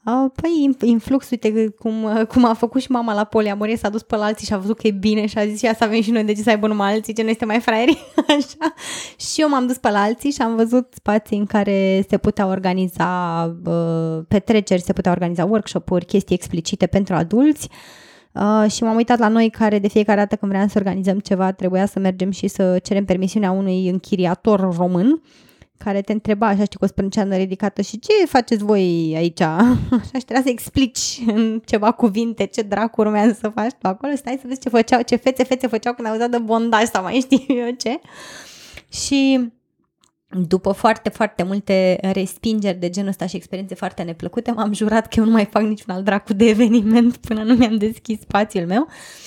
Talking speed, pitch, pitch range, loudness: 210 wpm, 215 Hz, 195-235 Hz, -18 LUFS